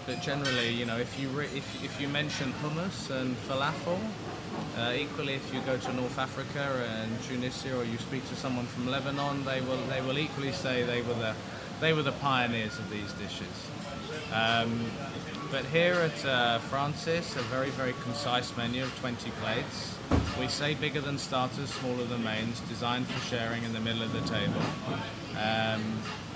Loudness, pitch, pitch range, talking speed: -32 LUFS, 130 Hz, 115-140 Hz, 180 wpm